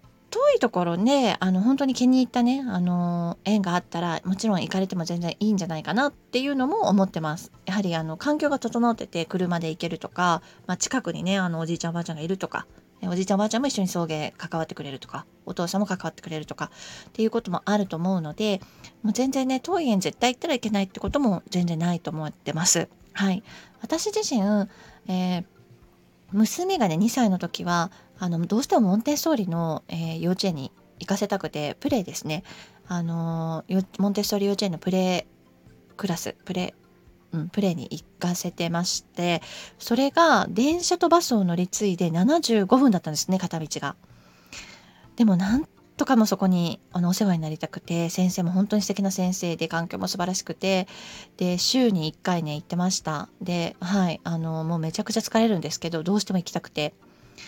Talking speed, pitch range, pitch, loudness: 380 characters per minute, 170-215 Hz, 185 Hz, -25 LUFS